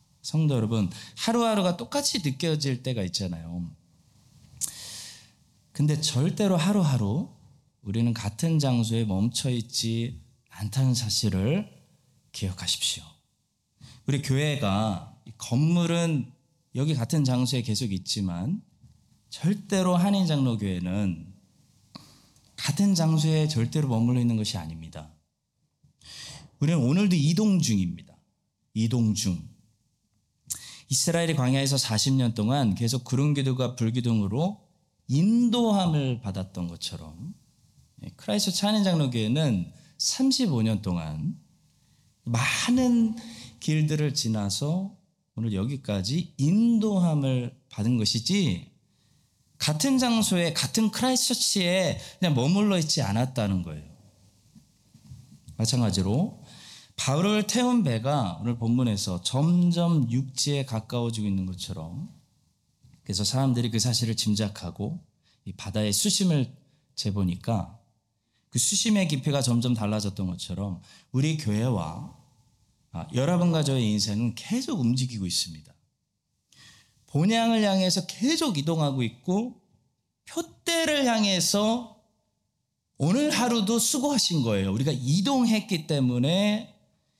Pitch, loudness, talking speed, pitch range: 130 Hz, -26 LUFS, 250 characters per minute, 110-175 Hz